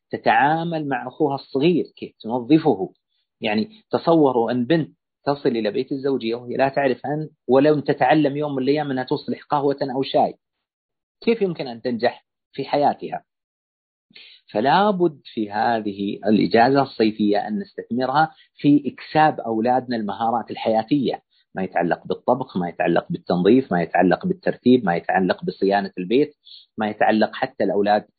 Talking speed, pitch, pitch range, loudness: 135 wpm, 135 Hz, 115-150 Hz, -21 LUFS